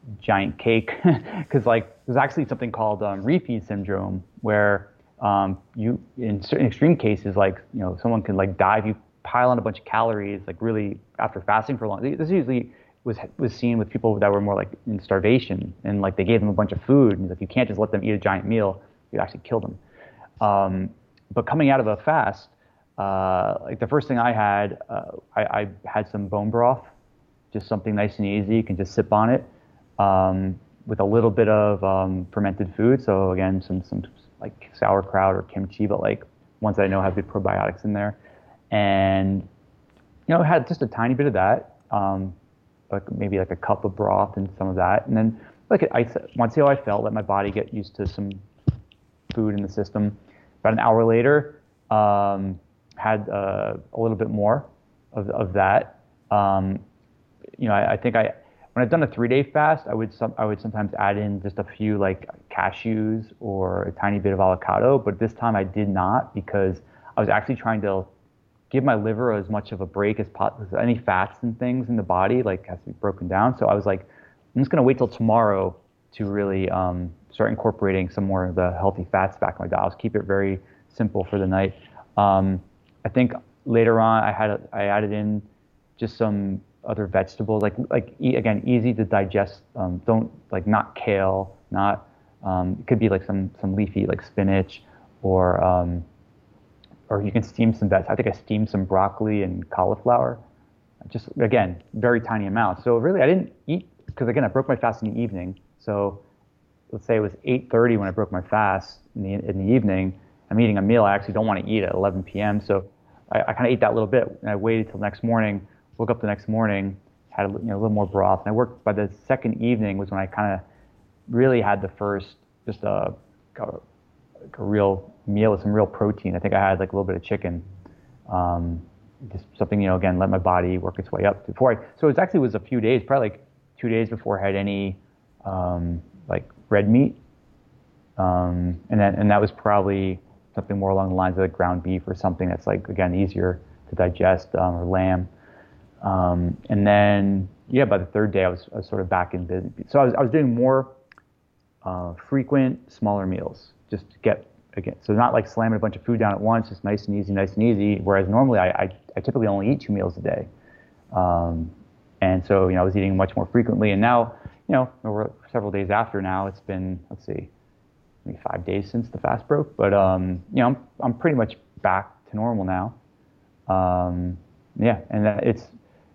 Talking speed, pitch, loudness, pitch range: 215 wpm, 100 Hz, -23 LUFS, 95-115 Hz